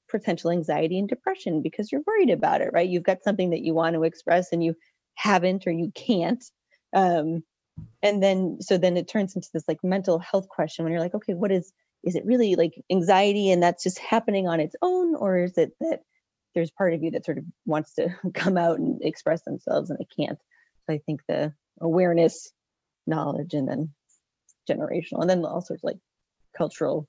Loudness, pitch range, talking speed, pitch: -25 LUFS, 165-195 Hz, 205 wpm, 180 Hz